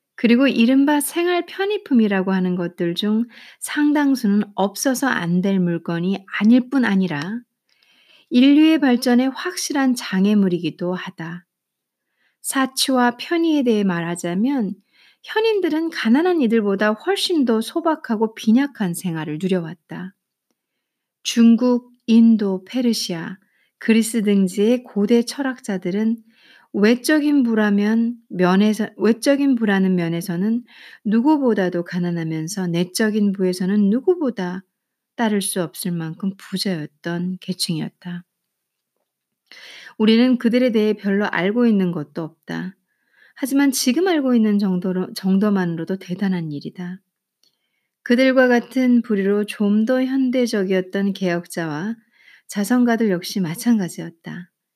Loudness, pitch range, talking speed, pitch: -19 LUFS, 185-250 Hz, 270 characters per minute, 215 Hz